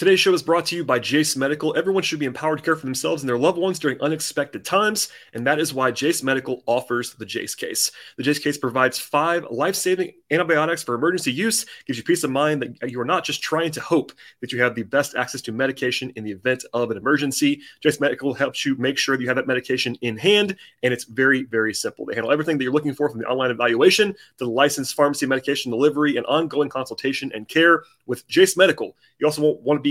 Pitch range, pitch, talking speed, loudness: 130-165 Hz, 145 Hz, 245 wpm, -21 LUFS